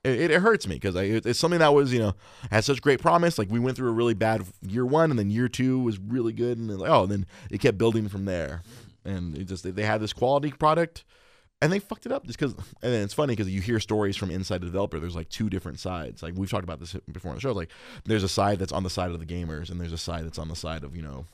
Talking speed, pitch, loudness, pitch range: 295 wpm, 105 Hz, -26 LUFS, 90-125 Hz